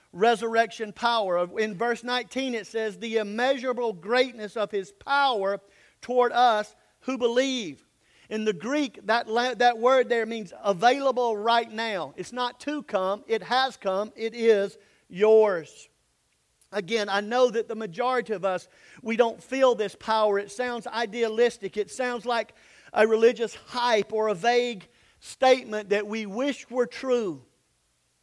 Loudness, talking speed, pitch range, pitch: -26 LUFS, 150 wpm, 210-245 Hz, 230 Hz